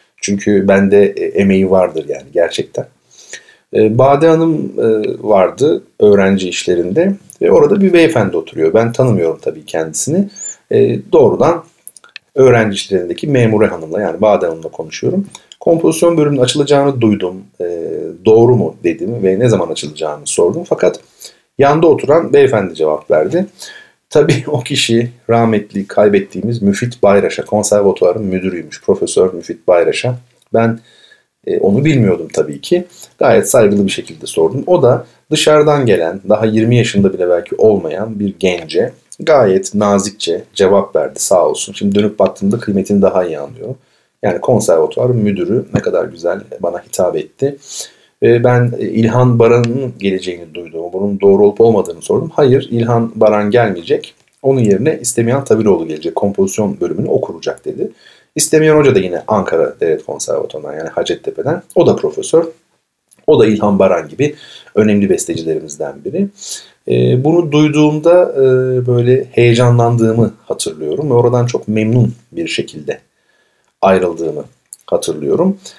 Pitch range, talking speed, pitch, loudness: 105-165 Hz, 125 wpm, 120 Hz, -13 LUFS